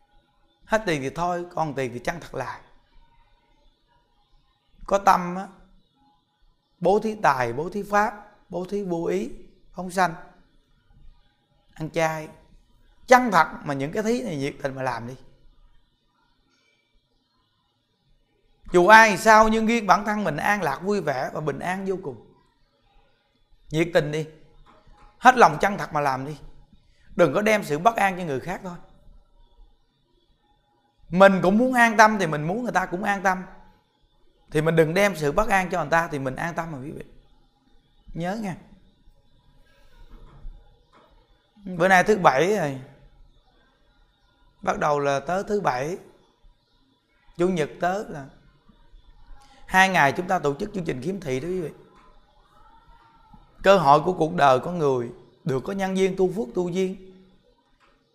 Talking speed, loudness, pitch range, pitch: 155 wpm, -22 LUFS, 140-195 Hz, 175 Hz